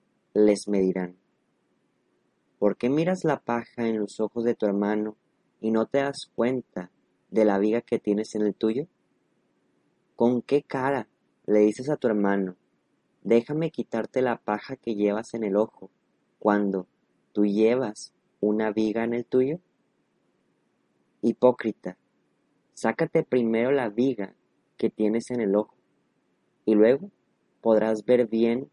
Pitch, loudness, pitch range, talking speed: 110 Hz, -26 LUFS, 105-125 Hz, 140 wpm